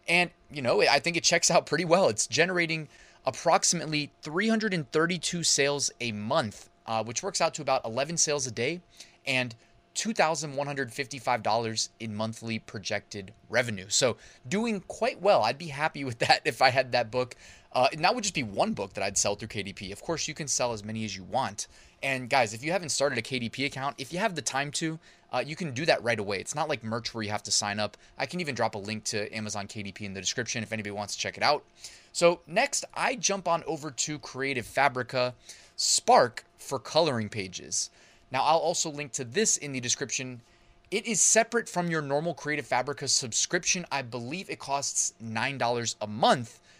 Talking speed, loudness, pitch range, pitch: 205 wpm, -28 LUFS, 110-160 Hz, 135 Hz